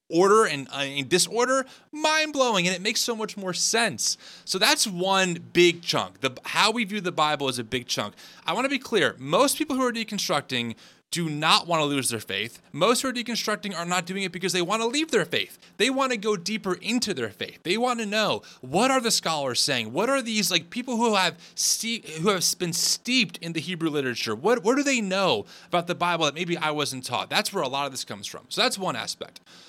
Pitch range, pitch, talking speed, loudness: 160-230 Hz, 190 Hz, 240 wpm, -24 LUFS